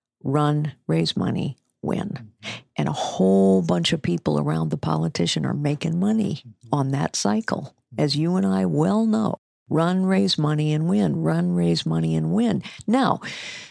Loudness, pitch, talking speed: -22 LUFS, 150 Hz, 160 wpm